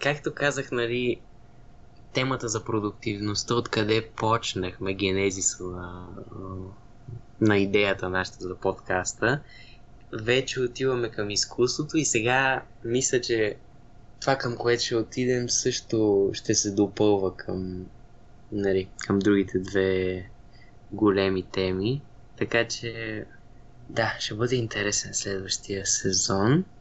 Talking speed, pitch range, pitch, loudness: 105 wpm, 100-120 Hz, 115 Hz, -26 LUFS